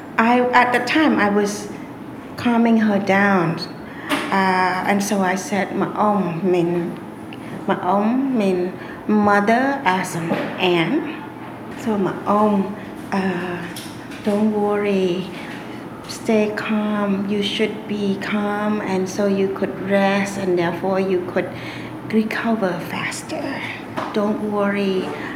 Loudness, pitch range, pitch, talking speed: -20 LUFS, 185-215 Hz, 200 Hz, 115 wpm